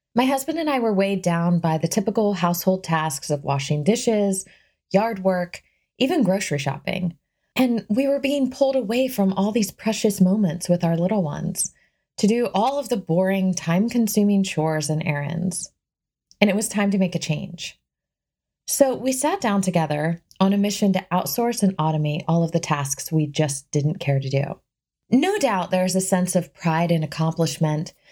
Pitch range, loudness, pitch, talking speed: 160-215 Hz, -22 LUFS, 185 Hz, 180 wpm